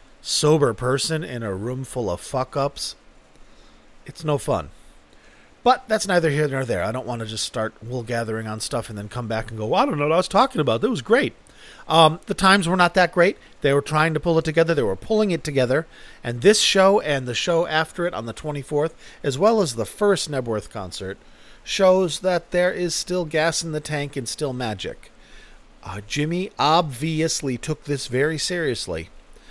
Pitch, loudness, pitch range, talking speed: 150 Hz, -22 LUFS, 125-175 Hz, 205 wpm